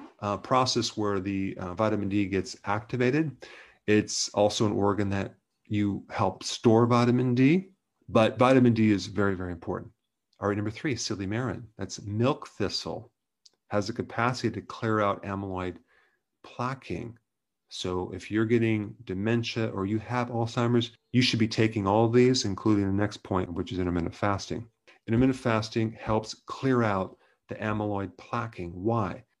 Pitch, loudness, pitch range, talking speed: 110 Hz, -28 LUFS, 100-120 Hz, 155 wpm